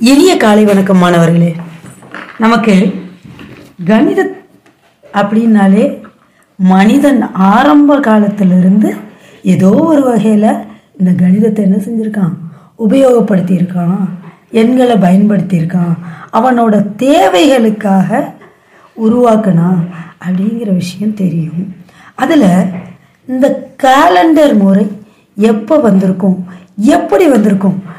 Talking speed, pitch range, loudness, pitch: 75 wpm, 180-235 Hz, -9 LUFS, 205 Hz